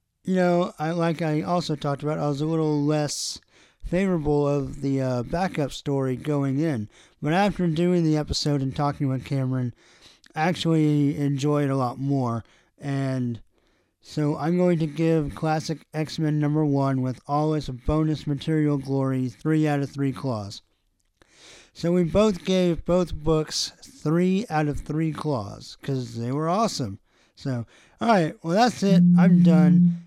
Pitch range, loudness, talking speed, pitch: 135-170 Hz, -24 LUFS, 160 wpm, 150 Hz